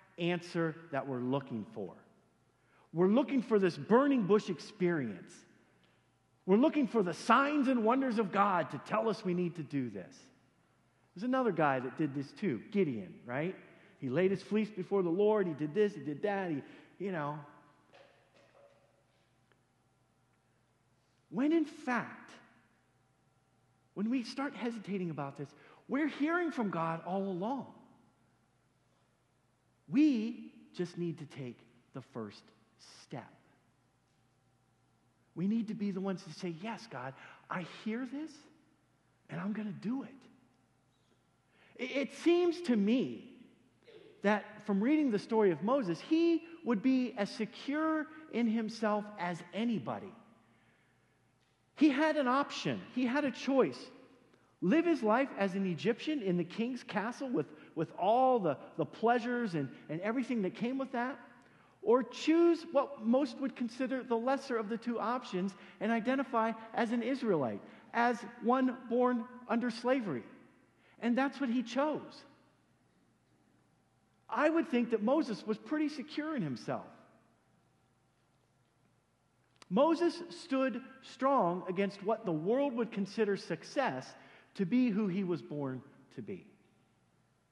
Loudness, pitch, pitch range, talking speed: -34 LUFS, 215 Hz, 170-255 Hz, 140 wpm